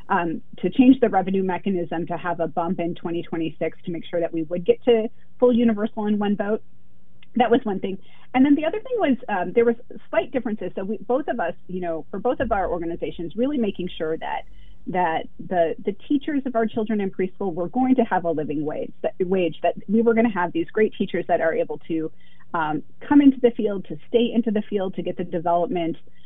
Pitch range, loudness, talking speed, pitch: 170-235 Hz, -23 LUFS, 230 wpm, 195 Hz